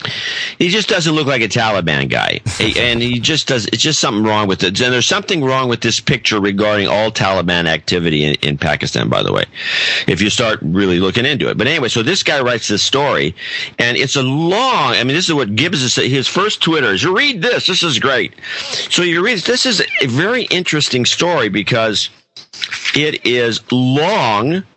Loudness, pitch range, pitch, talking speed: -14 LUFS, 105-155 Hz, 120 Hz, 205 wpm